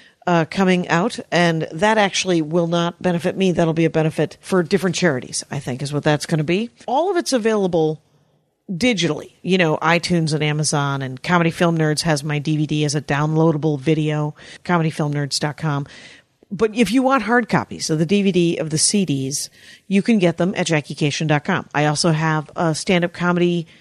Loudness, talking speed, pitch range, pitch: -19 LUFS, 180 wpm, 155-185 Hz, 165 Hz